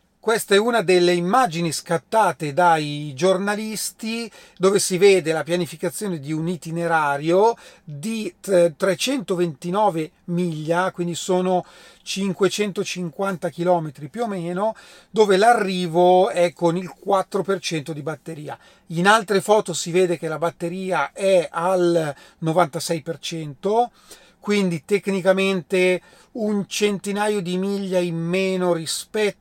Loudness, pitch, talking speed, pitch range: -21 LUFS, 180 Hz, 110 wpm, 170-200 Hz